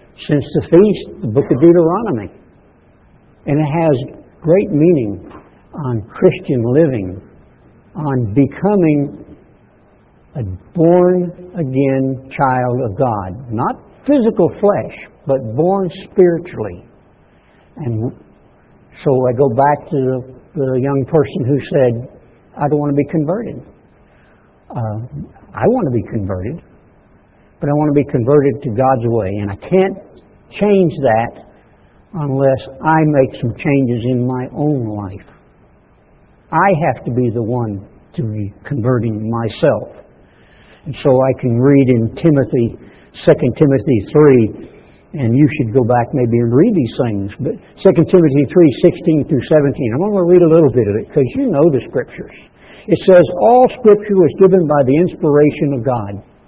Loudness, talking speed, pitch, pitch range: -14 LUFS, 145 wpm, 140 Hz, 120-165 Hz